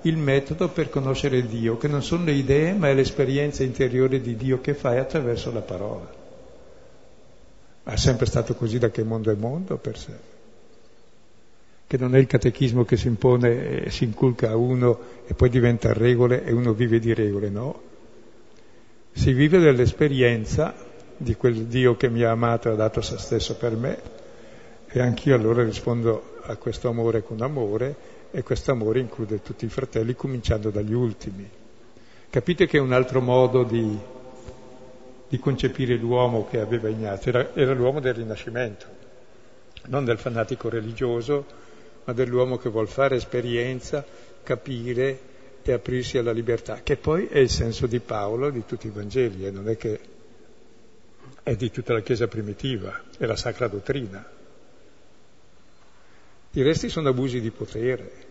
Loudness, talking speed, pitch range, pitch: -24 LUFS, 160 wpm, 115-130 Hz, 125 Hz